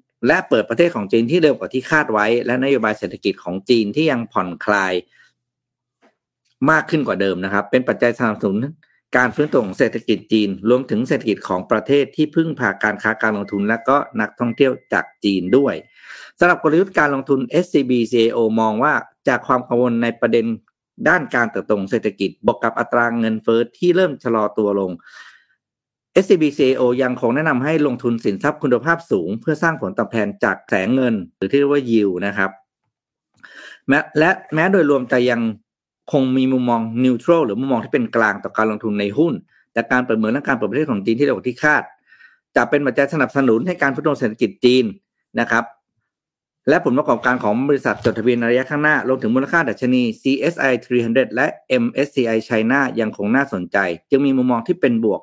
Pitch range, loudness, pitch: 110-140 Hz, -18 LUFS, 125 Hz